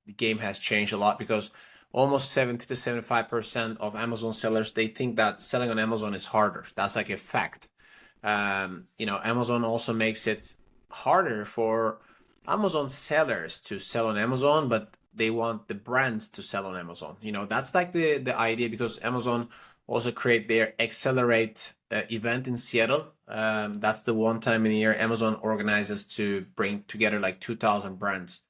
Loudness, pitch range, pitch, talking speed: -27 LUFS, 105-120 Hz, 115 Hz, 175 wpm